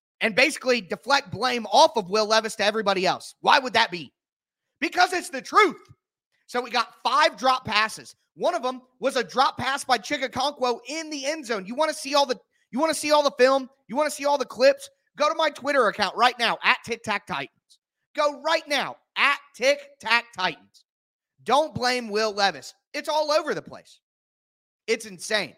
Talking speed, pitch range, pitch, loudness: 205 wpm, 220-290 Hz, 255 Hz, -23 LUFS